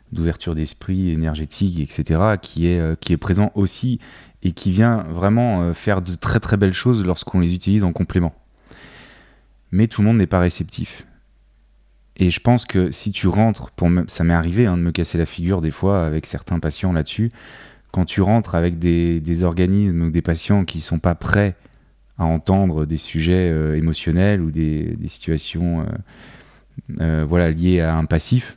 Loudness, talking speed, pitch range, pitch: -19 LUFS, 185 wpm, 80-100 Hz, 90 Hz